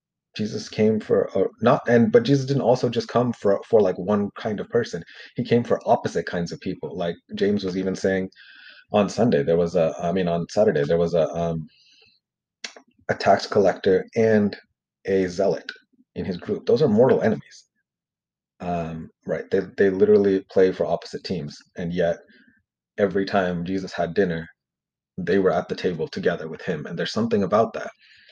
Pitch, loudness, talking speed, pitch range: 95 Hz, -22 LUFS, 180 wpm, 85-115 Hz